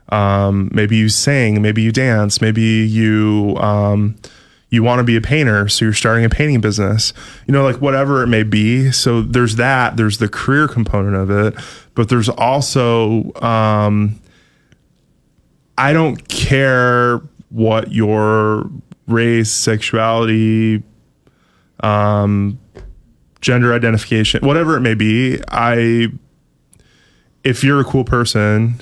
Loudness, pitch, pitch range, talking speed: -14 LUFS, 115 Hz, 105-125 Hz, 130 wpm